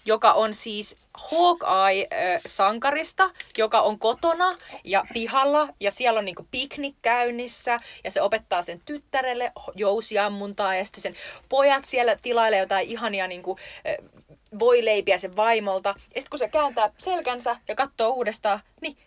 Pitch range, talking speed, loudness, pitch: 205-275 Hz, 140 wpm, -24 LUFS, 230 Hz